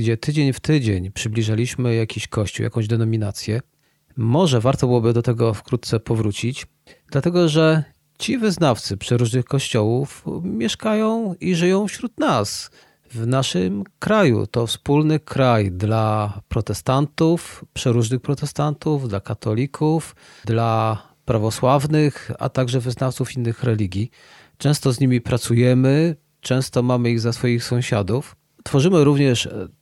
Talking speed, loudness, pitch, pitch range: 115 wpm, -20 LUFS, 125 Hz, 115-150 Hz